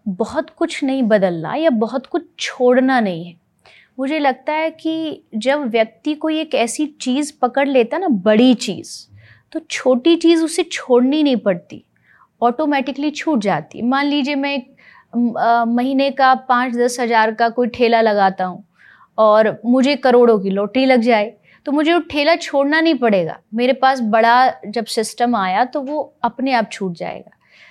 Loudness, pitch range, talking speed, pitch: -17 LUFS, 225-285 Hz, 160 wpm, 250 Hz